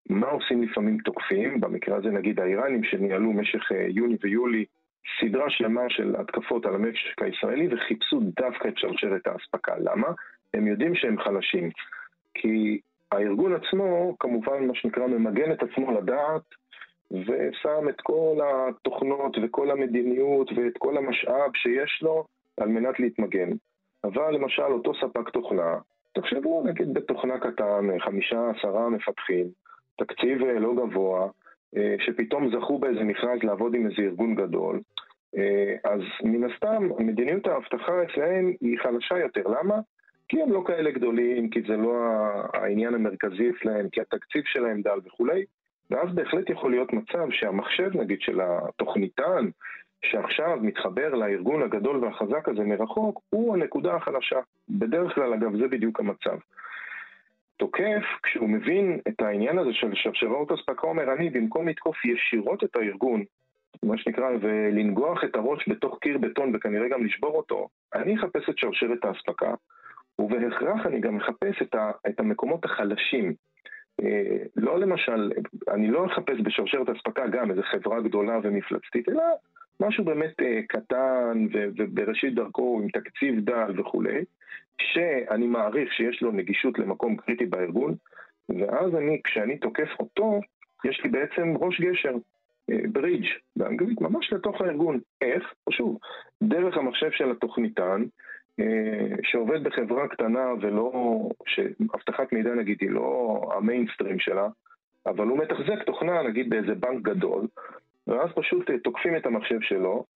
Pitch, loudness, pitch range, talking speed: 120 Hz, -27 LUFS, 110-165 Hz, 135 wpm